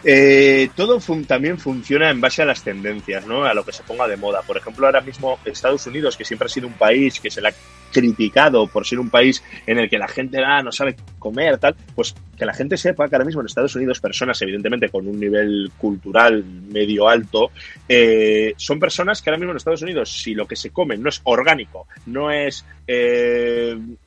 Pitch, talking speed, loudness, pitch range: 125 Hz, 220 wpm, -18 LUFS, 105-145 Hz